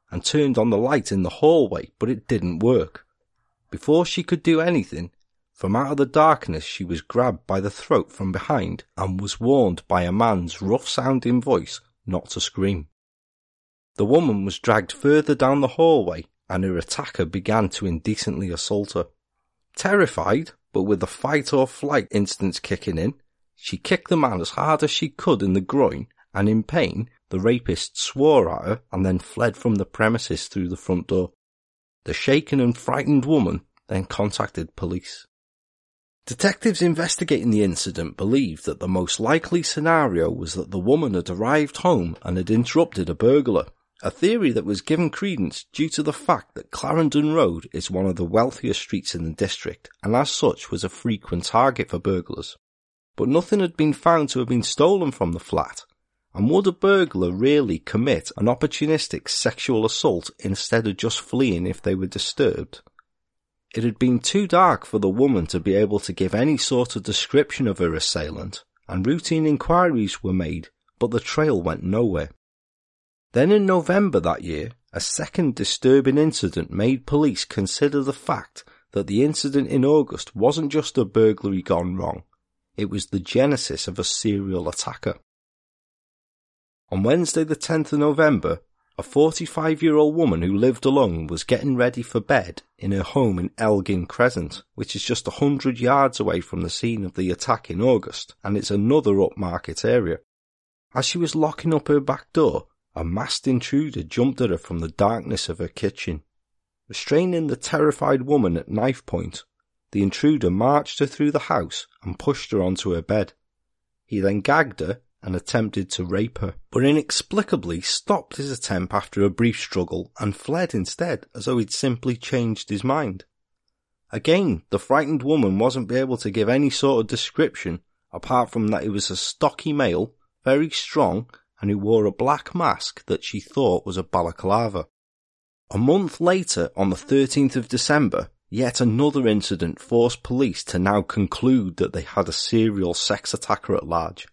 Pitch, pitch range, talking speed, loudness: 115 Hz, 95-145 Hz, 175 wpm, -22 LUFS